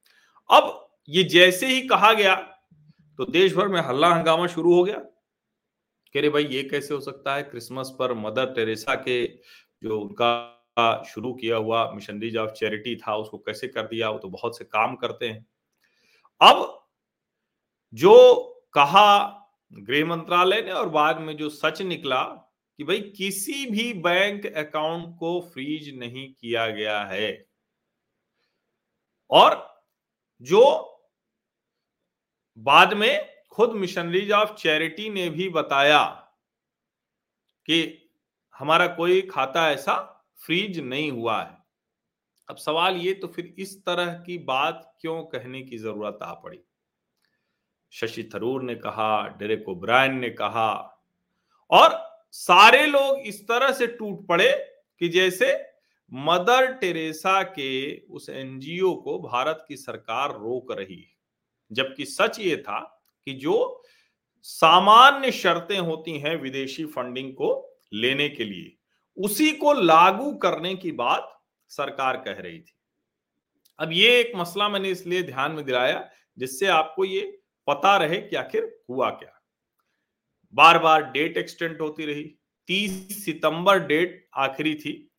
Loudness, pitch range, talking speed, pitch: -21 LUFS, 135-195 Hz, 135 wpm, 165 Hz